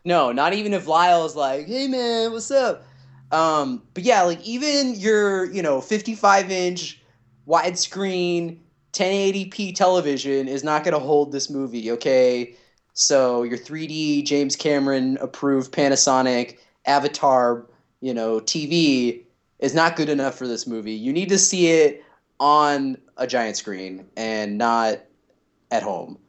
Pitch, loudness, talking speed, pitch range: 145 Hz, -21 LUFS, 140 wpm, 130-185 Hz